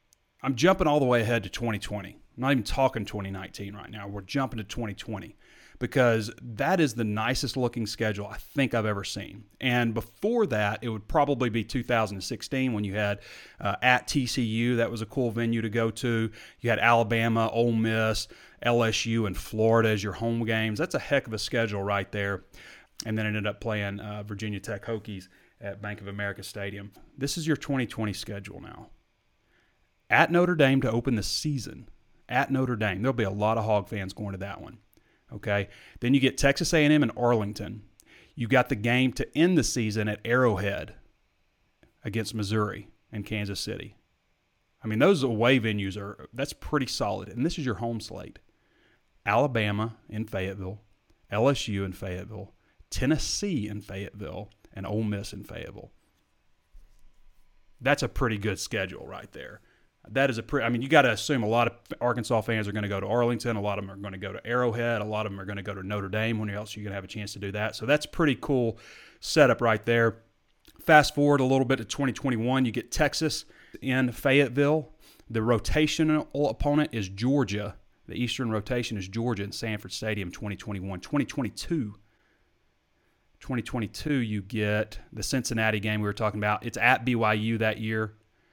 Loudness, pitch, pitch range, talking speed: -27 LUFS, 110 Hz, 105-125 Hz, 185 wpm